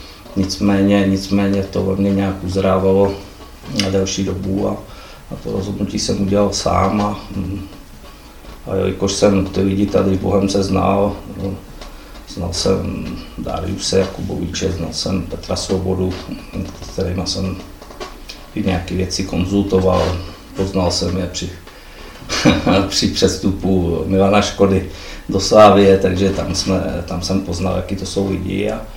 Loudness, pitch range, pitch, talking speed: -17 LUFS, 95-100 Hz, 95 Hz, 130 wpm